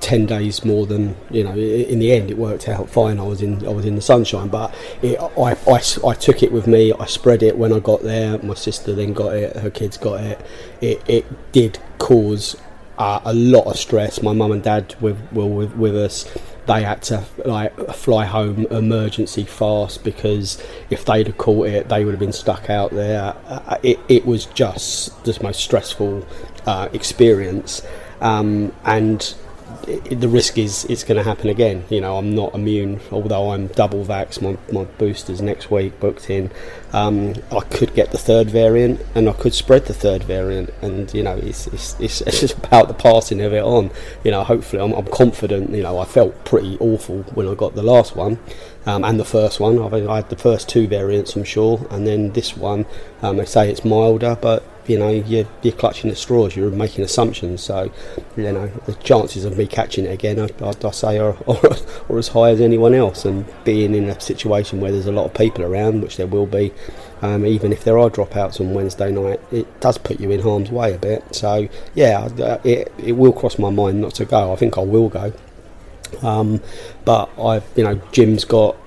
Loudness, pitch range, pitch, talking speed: -18 LUFS, 100-110 Hz, 105 Hz, 210 wpm